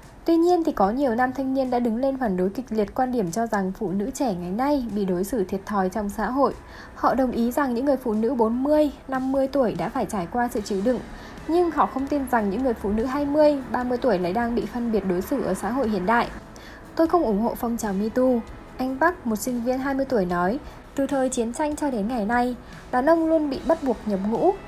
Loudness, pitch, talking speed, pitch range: -24 LUFS, 245 Hz, 255 wpm, 210-275 Hz